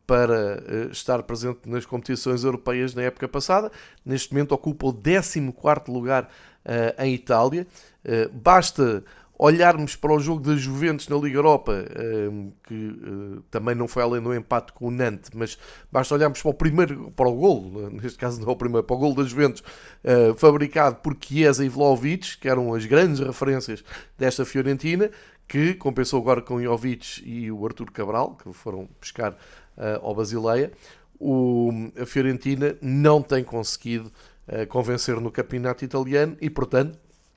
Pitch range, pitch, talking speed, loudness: 120-145 Hz, 130 Hz, 155 wpm, -23 LUFS